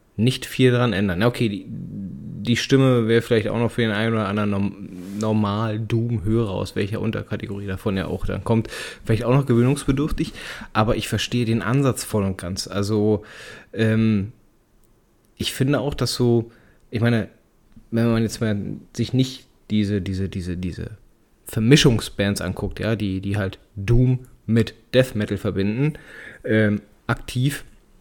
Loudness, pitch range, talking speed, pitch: -22 LUFS, 105-120 Hz, 155 wpm, 110 Hz